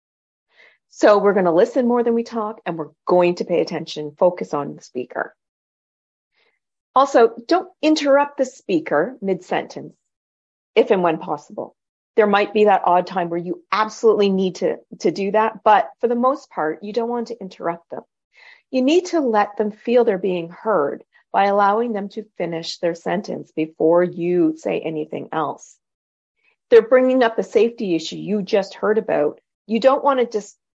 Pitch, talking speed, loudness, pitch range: 210 Hz, 180 wpm, -19 LUFS, 180-245 Hz